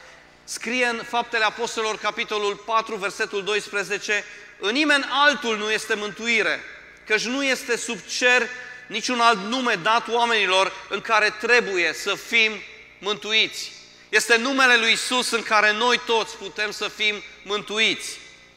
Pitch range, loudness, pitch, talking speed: 210-235 Hz, -21 LUFS, 220 Hz, 135 wpm